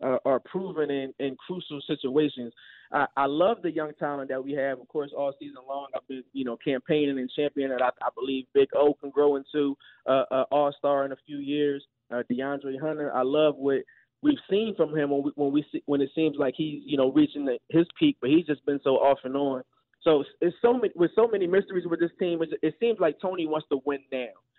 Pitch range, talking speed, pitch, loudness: 135-160 Hz, 245 wpm, 145 Hz, -27 LUFS